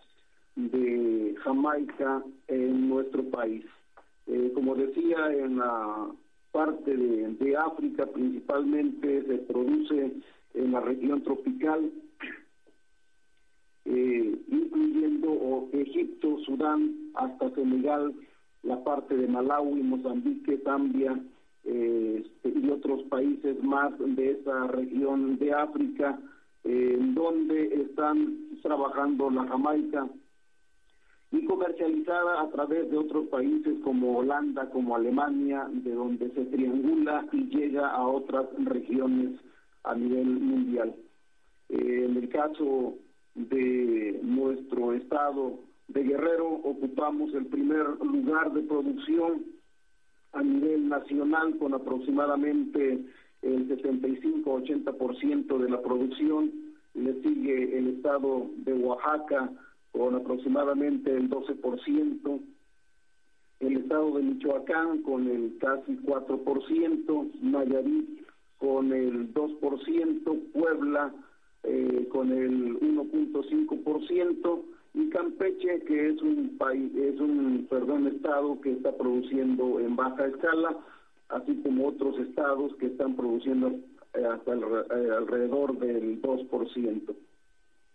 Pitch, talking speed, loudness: 140 Hz, 105 wpm, -29 LUFS